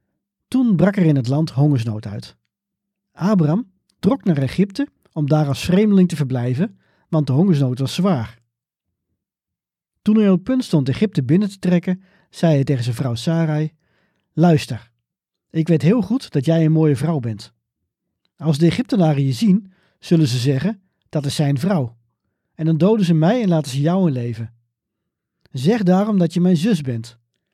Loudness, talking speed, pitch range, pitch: -18 LUFS, 175 wpm, 135-190 Hz, 160 Hz